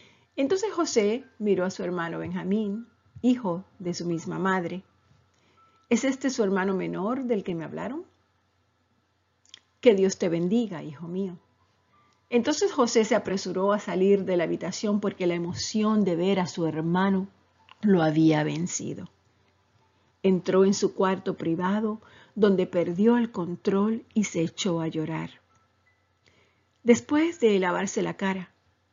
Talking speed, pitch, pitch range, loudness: 135 wpm, 190 Hz, 165-215 Hz, -26 LUFS